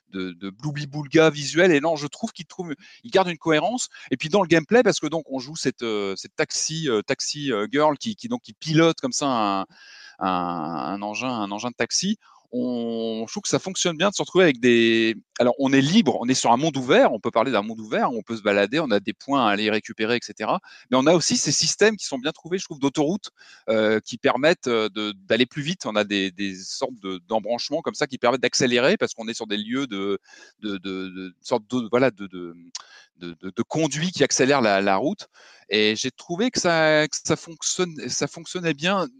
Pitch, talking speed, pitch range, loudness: 130 Hz, 210 wpm, 105-160 Hz, -23 LUFS